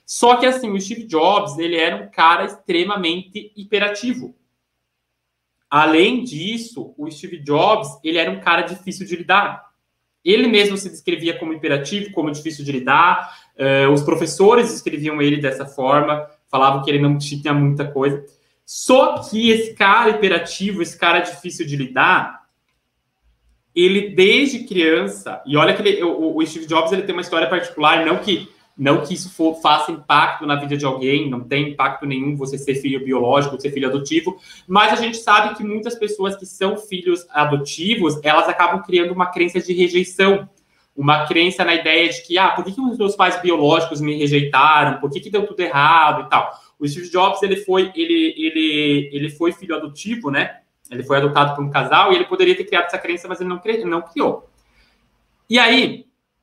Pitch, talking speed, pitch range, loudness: 170 Hz, 180 wpm, 145-200 Hz, -17 LUFS